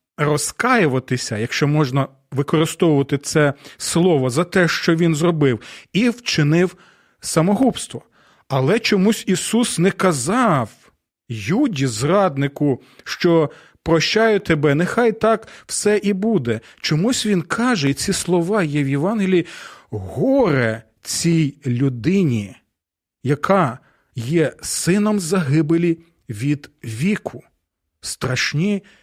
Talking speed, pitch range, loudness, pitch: 100 wpm, 140-195 Hz, -19 LUFS, 165 Hz